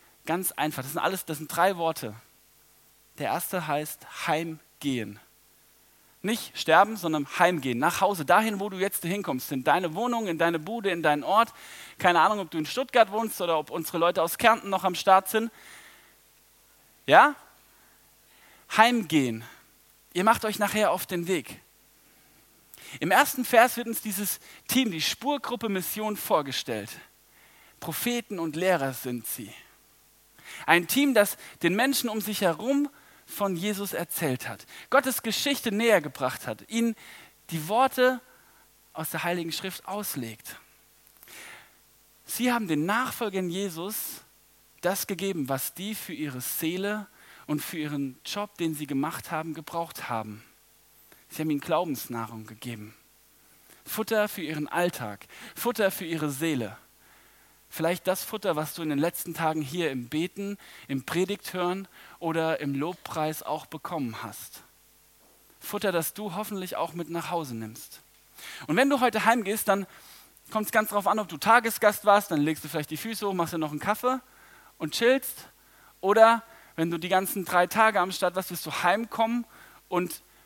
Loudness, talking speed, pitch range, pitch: -27 LUFS, 155 wpm, 155-215 Hz, 180 Hz